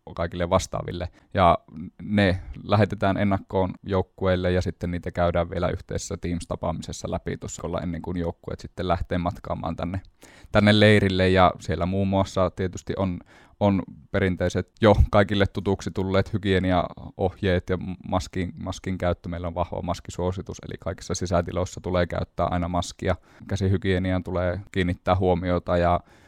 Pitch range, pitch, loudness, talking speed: 85-95 Hz, 90 Hz, -25 LUFS, 130 wpm